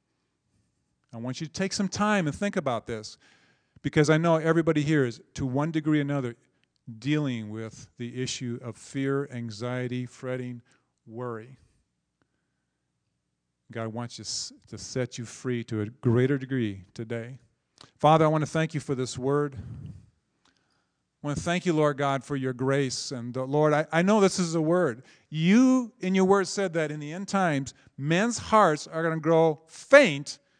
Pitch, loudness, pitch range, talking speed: 135 Hz, -26 LUFS, 120-160 Hz, 170 wpm